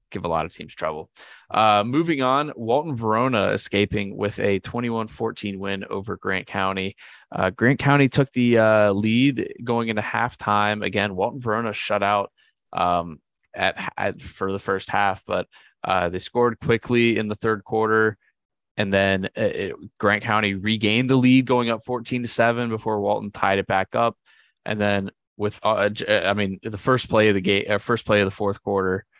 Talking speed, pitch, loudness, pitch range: 185 wpm, 105 Hz, -22 LUFS, 100-115 Hz